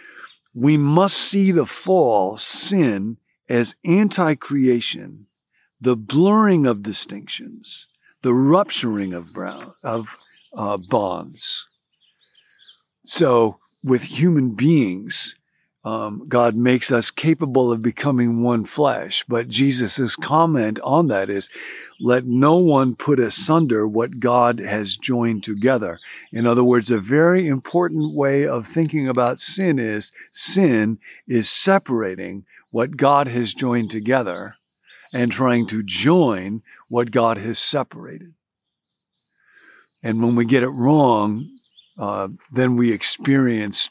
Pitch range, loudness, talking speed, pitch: 115-145 Hz, -19 LUFS, 120 wpm, 125 Hz